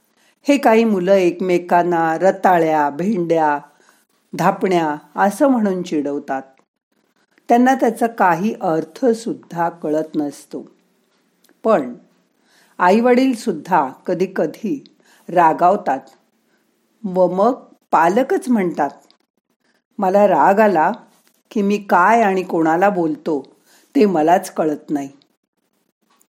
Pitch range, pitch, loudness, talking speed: 160-225 Hz, 185 Hz, -17 LUFS, 85 wpm